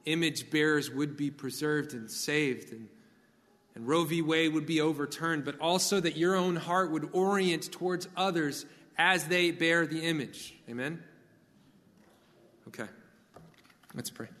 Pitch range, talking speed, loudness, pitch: 150-175 Hz, 140 wpm, -30 LUFS, 160 Hz